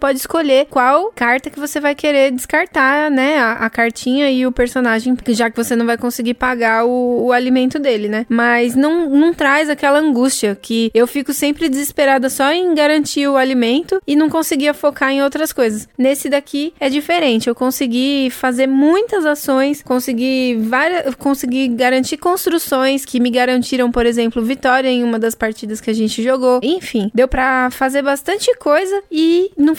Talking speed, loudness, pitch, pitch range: 175 wpm, -15 LUFS, 265 Hz, 245-295 Hz